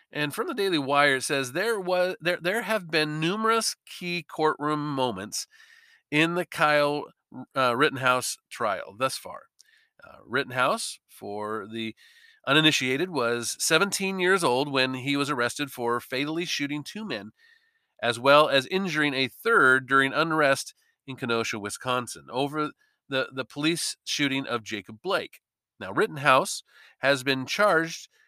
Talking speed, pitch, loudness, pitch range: 140 wpm, 145 Hz, -25 LUFS, 130-175 Hz